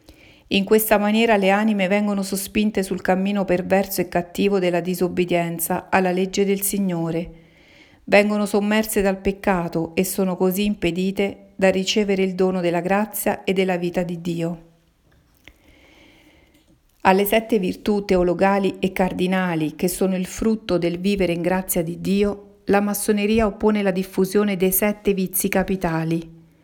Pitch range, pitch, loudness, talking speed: 180-205 Hz, 190 Hz, -21 LUFS, 140 wpm